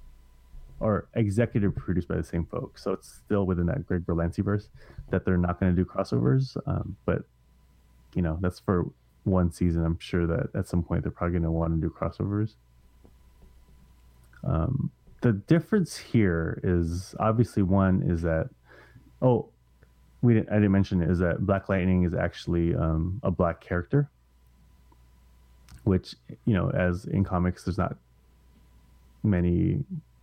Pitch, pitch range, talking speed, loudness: 85 Hz, 65-95 Hz, 155 wpm, -27 LUFS